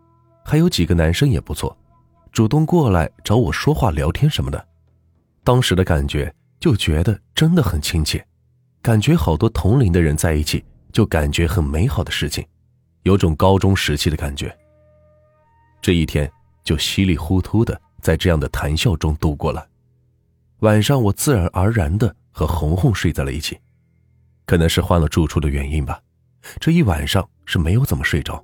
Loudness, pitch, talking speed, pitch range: -18 LUFS, 90 Hz, 255 characters per minute, 80-115 Hz